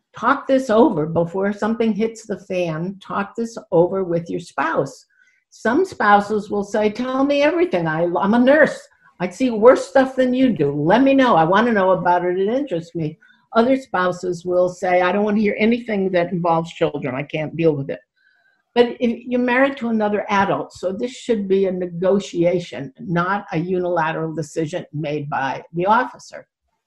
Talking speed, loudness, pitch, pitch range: 185 wpm, -19 LUFS, 200 Hz, 175-245 Hz